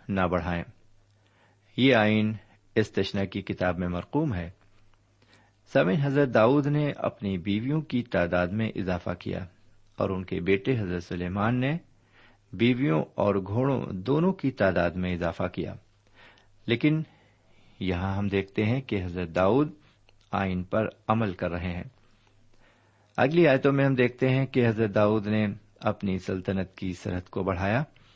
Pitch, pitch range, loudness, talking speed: 105 Hz, 95-120 Hz, -27 LUFS, 145 wpm